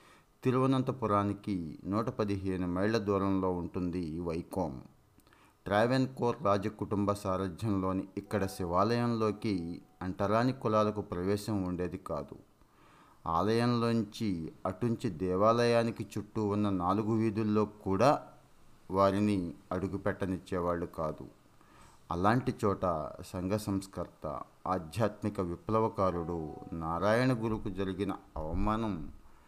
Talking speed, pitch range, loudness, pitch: 80 wpm, 90-110 Hz, -33 LUFS, 100 Hz